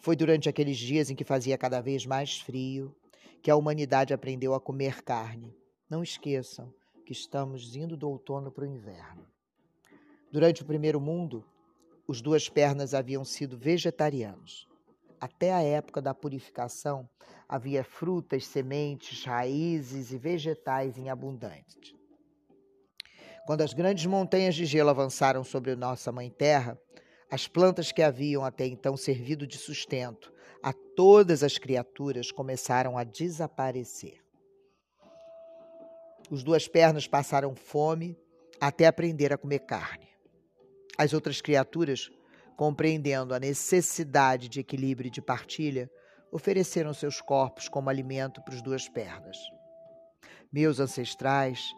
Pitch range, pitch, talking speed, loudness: 130-160 Hz, 140 Hz, 125 wpm, -29 LUFS